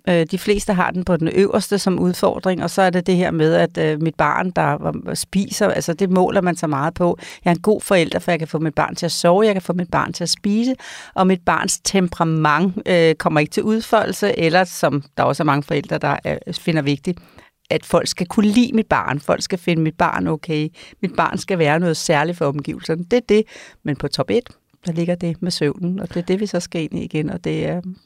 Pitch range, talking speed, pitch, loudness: 160-195 Hz, 245 wpm, 175 Hz, -19 LUFS